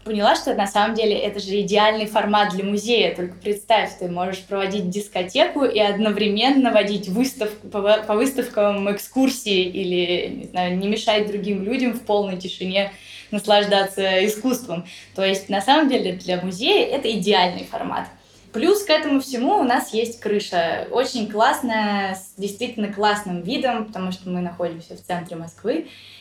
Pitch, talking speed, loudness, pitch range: 205 Hz, 155 wpm, -21 LUFS, 190-225 Hz